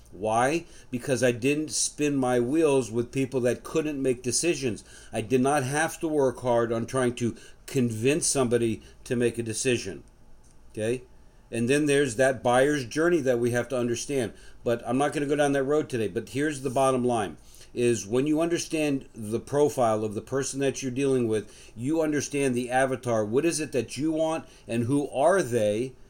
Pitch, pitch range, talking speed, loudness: 130 Hz, 120-145 Hz, 190 wpm, -26 LUFS